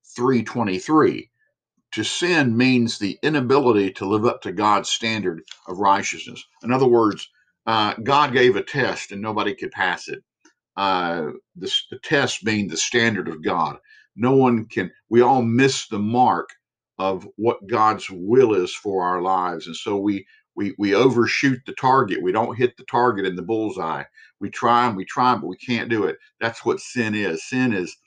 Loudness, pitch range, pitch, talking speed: -21 LUFS, 100-135 Hz, 115 Hz, 180 wpm